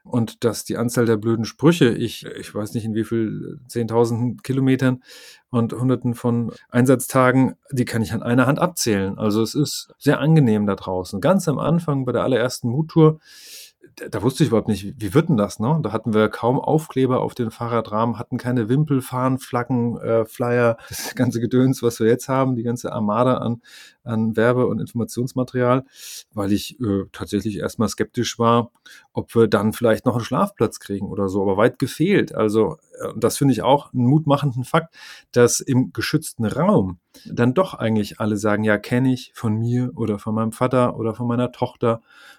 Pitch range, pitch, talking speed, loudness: 110-130 Hz, 120 Hz, 185 wpm, -20 LUFS